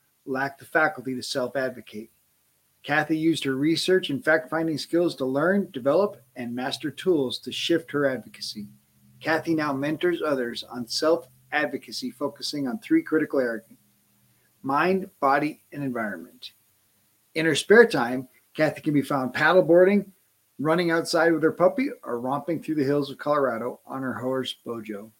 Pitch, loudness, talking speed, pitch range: 145 Hz, -25 LUFS, 150 wpm, 125-165 Hz